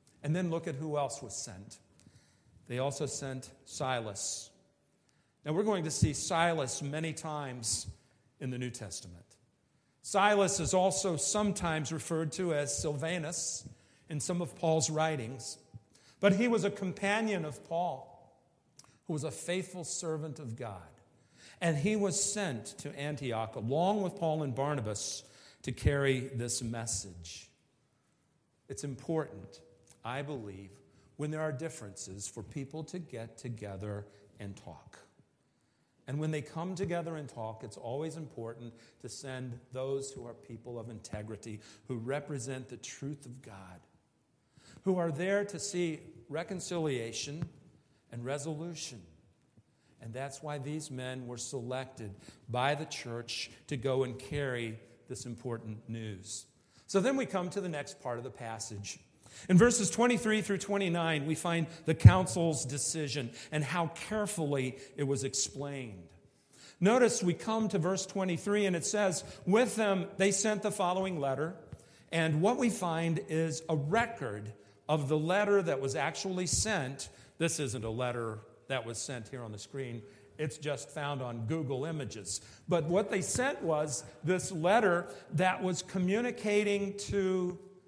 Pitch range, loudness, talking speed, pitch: 120-175 Hz, -33 LUFS, 145 wpm, 145 Hz